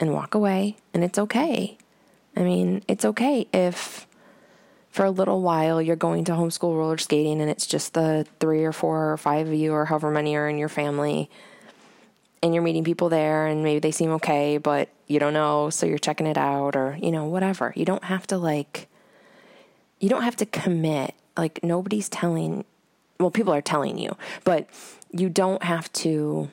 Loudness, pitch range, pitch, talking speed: -24 LUFS, 150-180 Hz, 160 Hz, 190 wpm